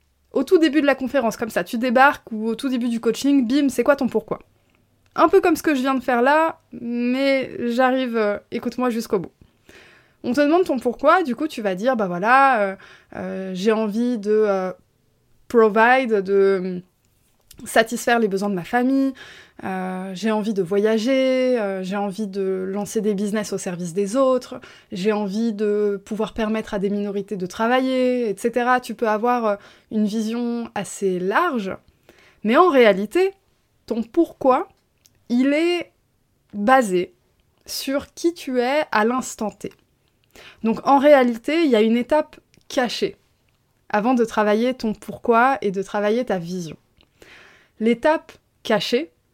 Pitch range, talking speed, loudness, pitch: 205-260 Hz, 165 wpm, -20 LUFS, 230 Hz